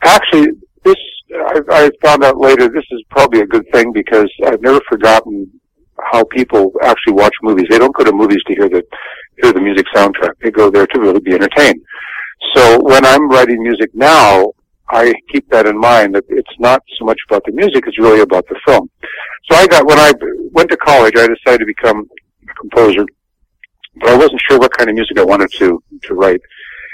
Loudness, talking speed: -9 LUFS, 205 wpm